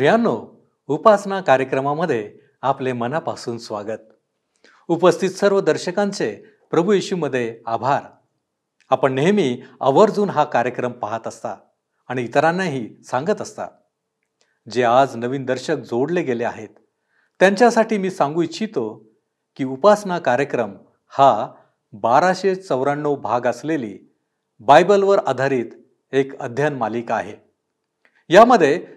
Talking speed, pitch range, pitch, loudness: 95 wpm, 130-190 Hz, 145 Hz, -19 LUFS